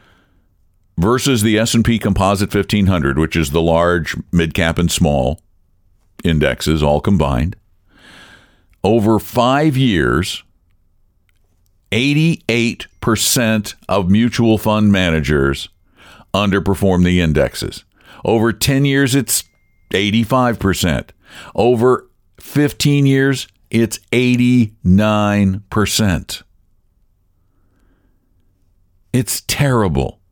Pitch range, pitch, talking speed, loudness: 90-115 Hz, 95 Hz, 95 wpm, -15 LUFS